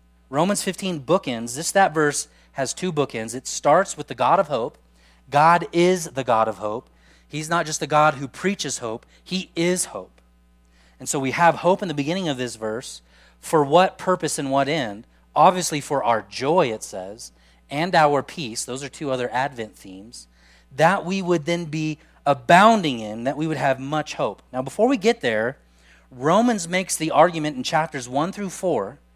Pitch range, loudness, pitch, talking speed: 110-170 Hz, -22 LUFS, 145 Hz, 190 wpm